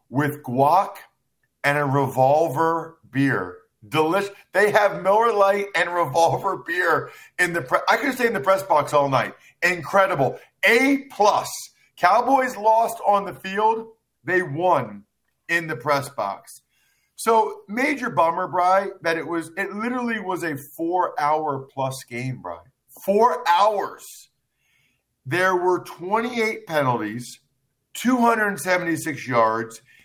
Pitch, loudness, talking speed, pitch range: 175 Hz, -21 LUFS, 125 wpm, 140-205 Hz